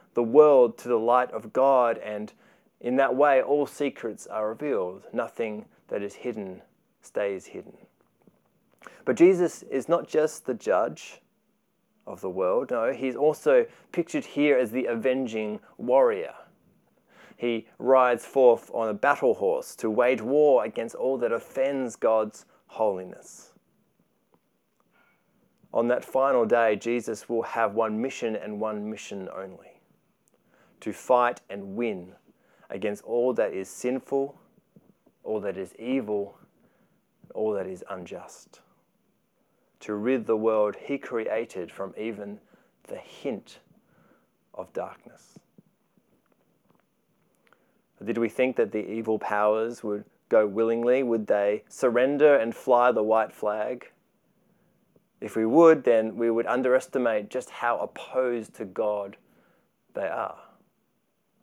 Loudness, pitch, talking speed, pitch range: -26 LUFS, 120 Hz, 125 wpm, 110-140 Hz